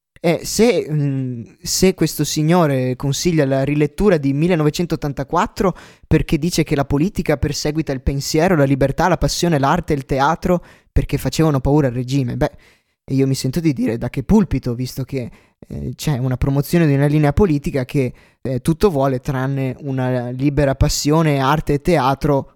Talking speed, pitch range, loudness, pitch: 165 wpm, 135-160 Hz, -18 LUFS, 145 Hz